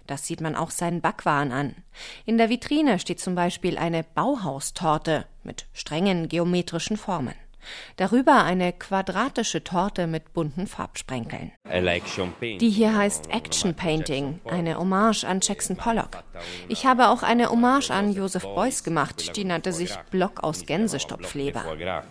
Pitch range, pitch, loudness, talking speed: 155-205 Hz, 175 Hz, -24 LUFS, 140 wpm